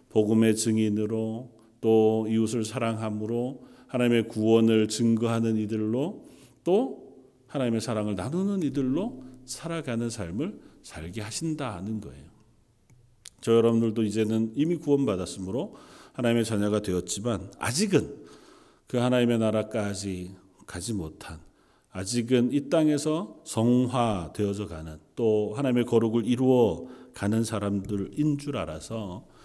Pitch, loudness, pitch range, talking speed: 115 Hz, -27 LUFS, 105-125 Hz, 285 characters per minute